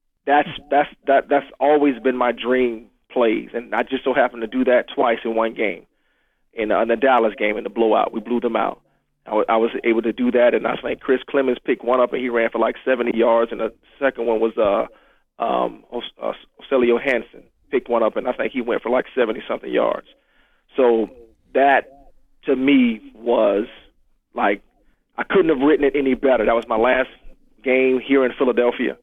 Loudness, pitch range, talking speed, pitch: -20 LUFS, 115-135 Hz, 205 wpm, 125 Hz